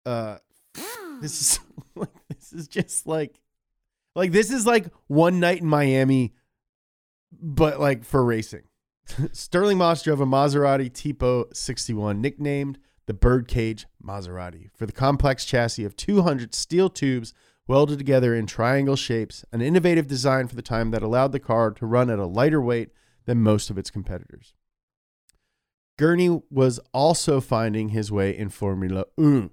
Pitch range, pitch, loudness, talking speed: 110-145 Hz, 130 Hz, -23 LUFS, 150 wpm